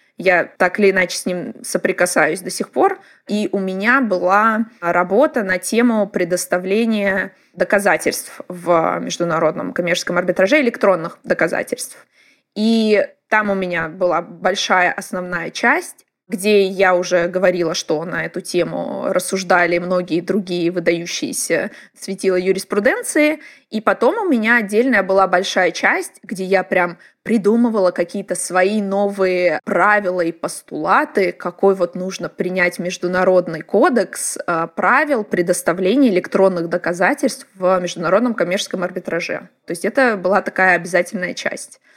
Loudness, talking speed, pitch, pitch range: -17 LUFS, 125 wpm, 190 Hz, 180-215 Hz